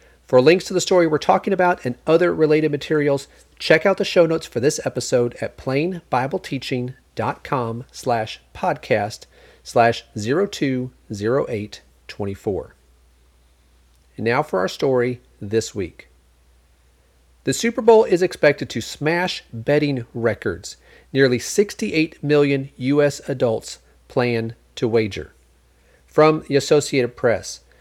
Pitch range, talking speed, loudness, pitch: 110-160 Hz, 115 wpm, -20 LUFS, 135 Hz